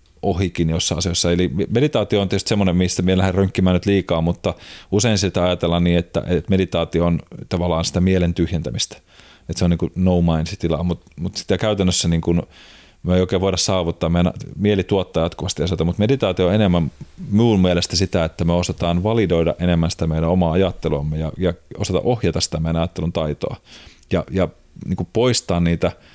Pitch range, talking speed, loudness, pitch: 85-95 Hz, 180 wpm, -19 LUFS, 90 Hz